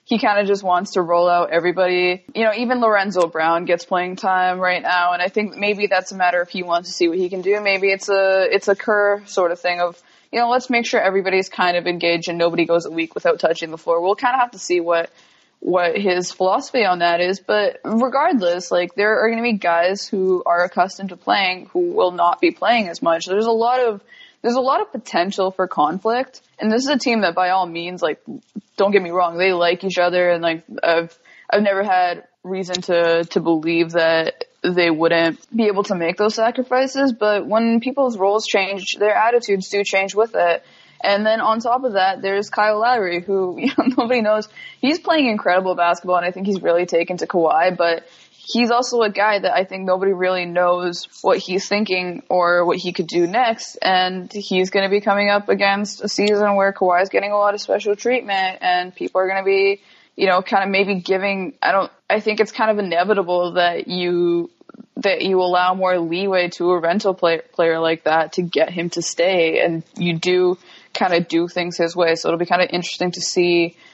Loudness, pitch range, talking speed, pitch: -18 LUFS, 175-215 Hz, 225 wpm, 190 Hz